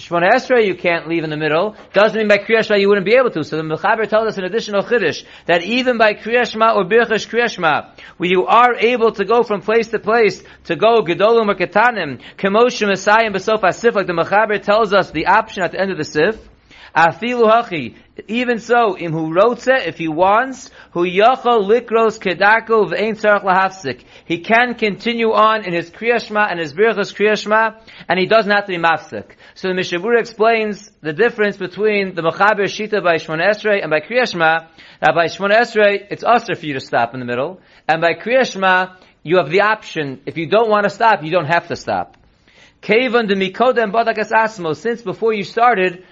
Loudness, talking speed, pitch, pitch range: -16 LUFS, 185 wpm, 205 Hz, 175-225 Hz